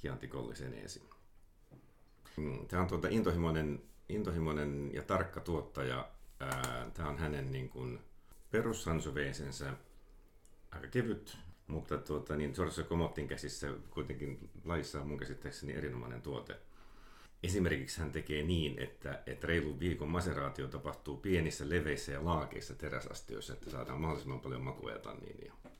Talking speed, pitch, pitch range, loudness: 110 wpm, 75 Hz, 70-85 Hz, -39 LUFS